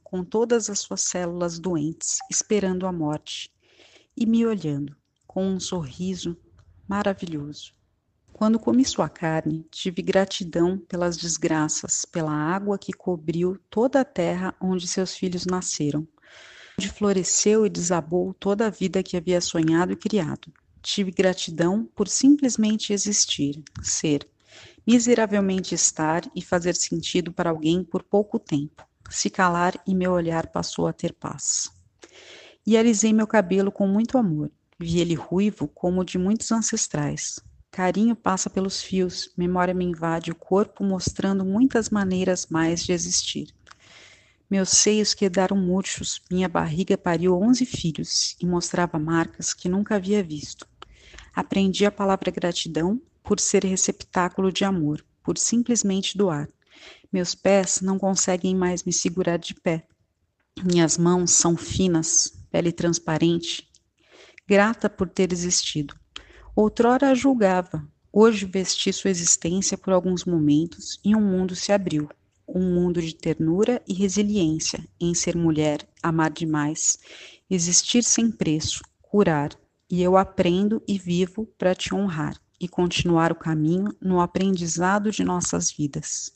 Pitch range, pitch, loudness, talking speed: 165-200 Hz, 185 Hz, -23 LUFS, 135 wpm